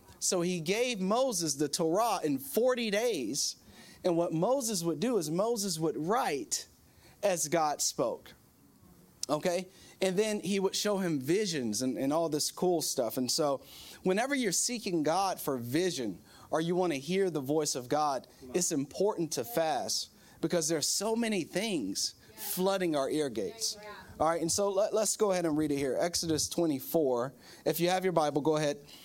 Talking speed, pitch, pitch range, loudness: 180 wpm, 175 Hz, 155-200 Hz, -31 LUFS